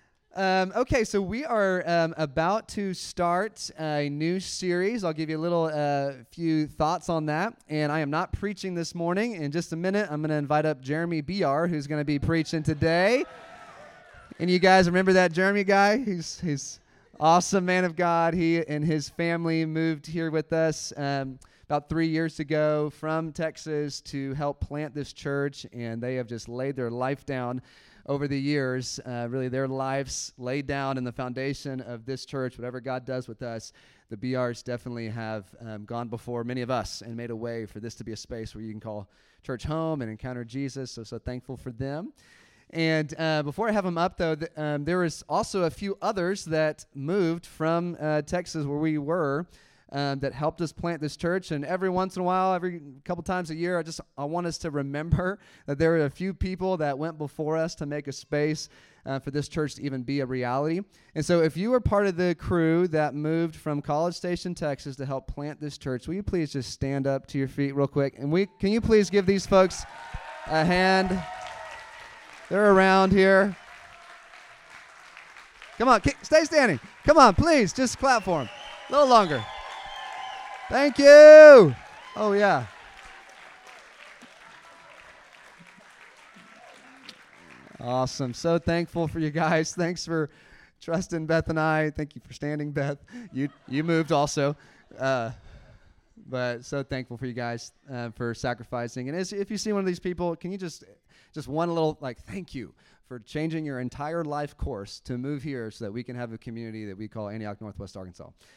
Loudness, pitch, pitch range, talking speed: -25 LUFS, 155 Hz, 130-175 Hz, 190 wpm